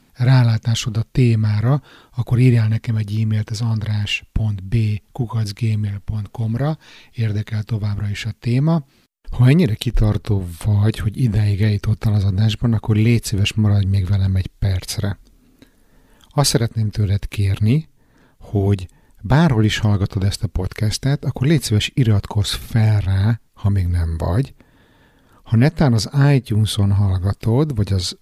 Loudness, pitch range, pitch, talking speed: -19 LUFS, 100-120 Hz, 110 Hz, 130 wpm